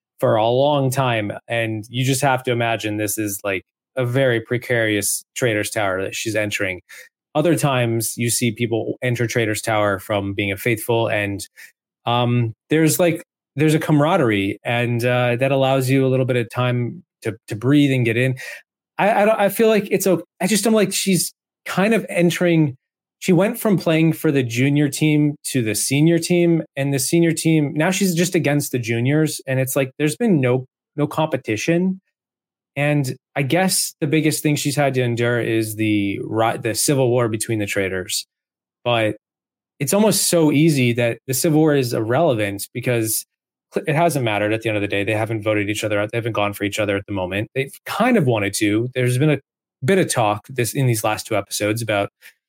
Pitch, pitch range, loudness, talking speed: 130 Hz, 110-155 Hz, -19 LUFS, 200 wpm